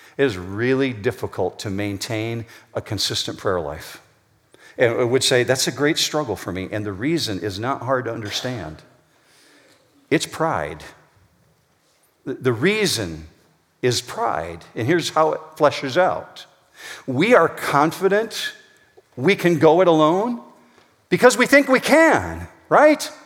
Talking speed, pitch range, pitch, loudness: 140 wpm, 115-185 Hz, 140 Hz, -19 LUFS